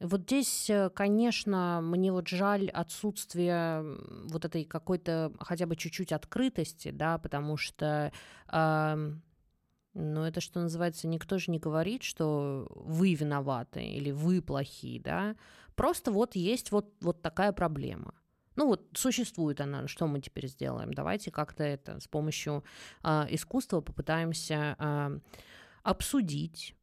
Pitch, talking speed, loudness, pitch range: 165 Hz, 130 wpm, -33 LUFS, 150-190 Hz